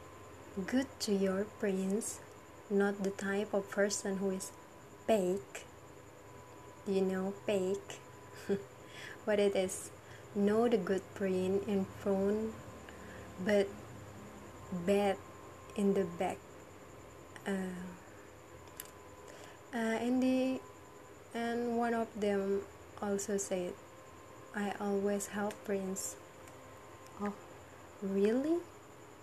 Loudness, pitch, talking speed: -36 LUFS, 190 Hz, 90 wpm